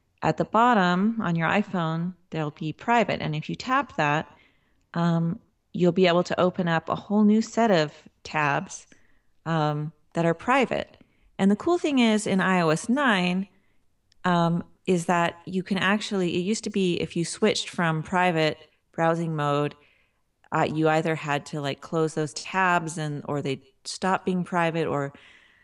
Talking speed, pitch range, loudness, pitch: 170 wpm, 155-195 Hz, -25 LUFS, 170 Hz